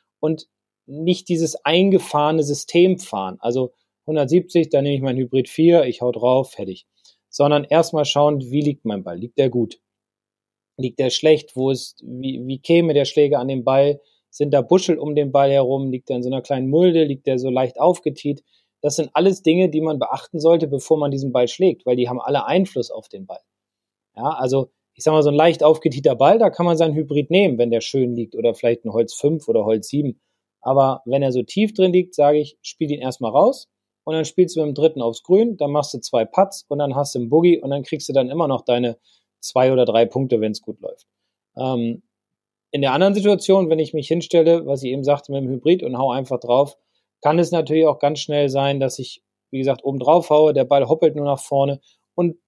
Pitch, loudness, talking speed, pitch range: 145 Hz, -19 LUFS, 230 wpm, 130-160 Hz